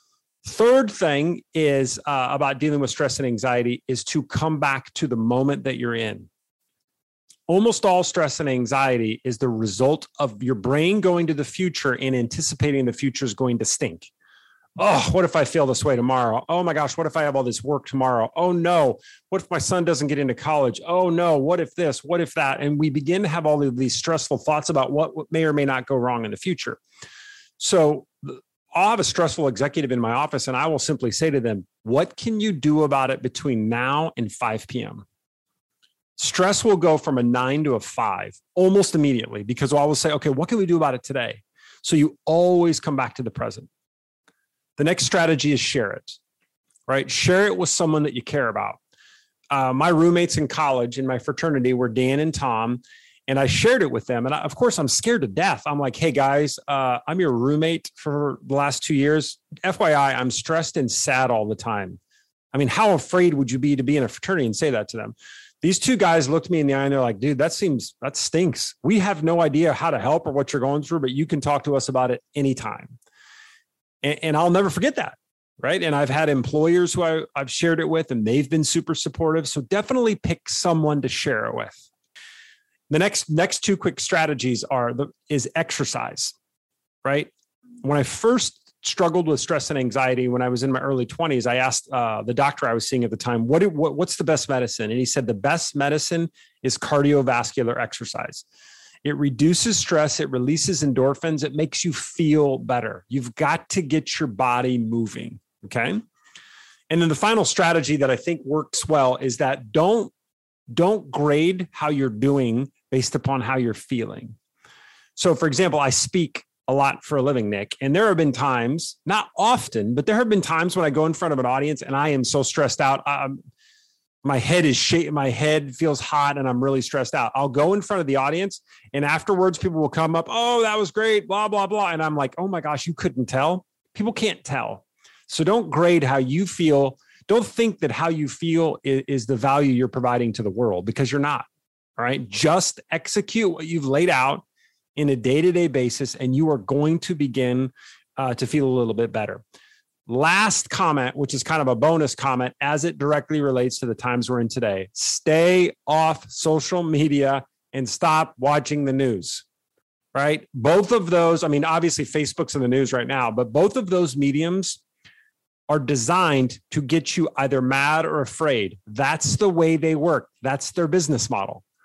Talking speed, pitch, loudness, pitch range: 205 wpm, 145 Hz, -22 LUFS, 130-170 Hz